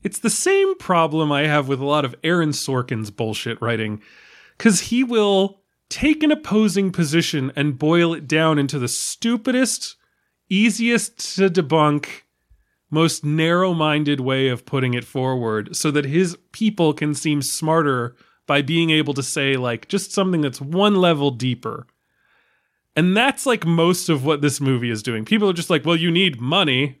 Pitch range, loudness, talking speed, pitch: 140-190 Hz, -19 LUFS, 170 wpm, 160 Hz